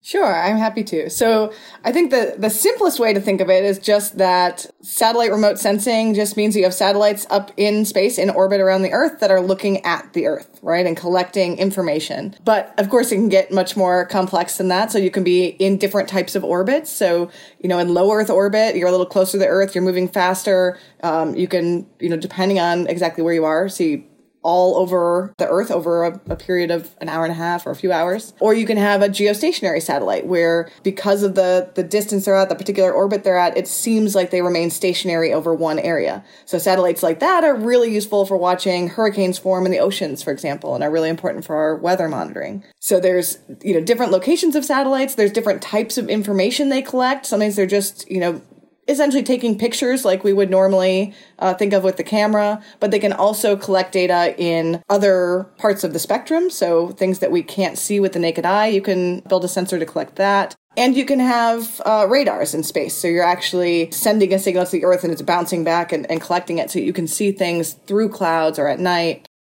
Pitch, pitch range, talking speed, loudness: 190 Hz, 180-210 Hz, 225 wpm, -18 LUFS